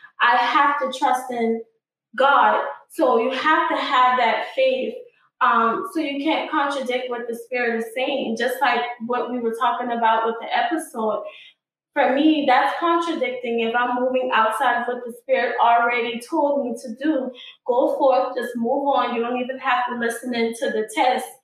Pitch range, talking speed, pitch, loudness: 235-280 Hz, 180 wpm, 250 Hz, -21 LUFS